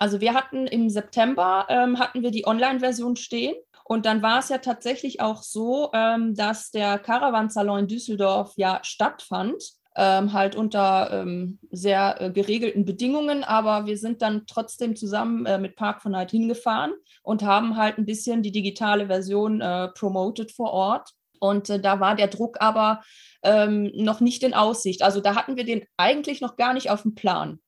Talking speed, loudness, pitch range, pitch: 185 wpm, -23 LUFS, 200-235 Hz, 215 Hz